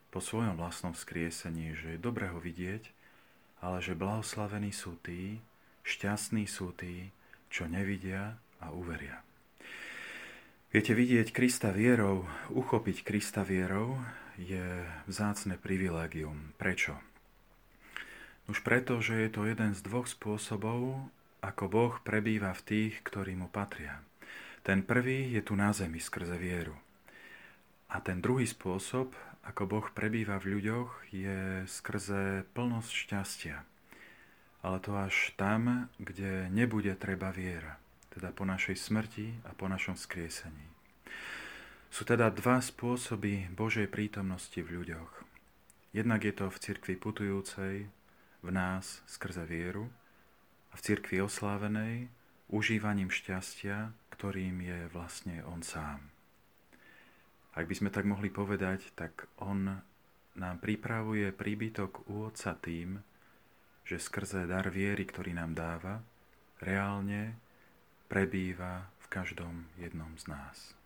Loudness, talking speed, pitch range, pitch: -36 LUFS, 120 wpm, 90-110 Hz, 100 Hz